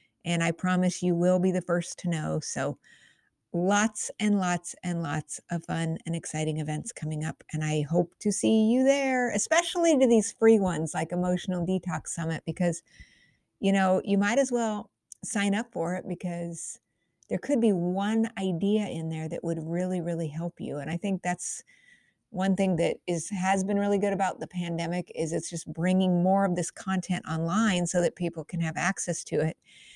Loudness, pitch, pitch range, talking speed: -28 LUFS, 180 Hz, 170-200 Hz, 190 wpm